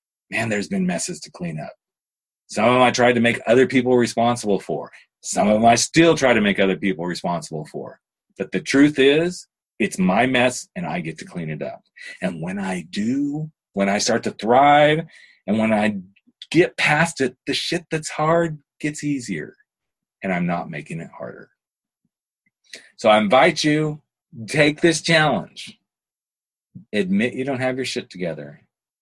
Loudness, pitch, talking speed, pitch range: -20 LUFS, 150 Hz, 175 wpm, 120-175 Hz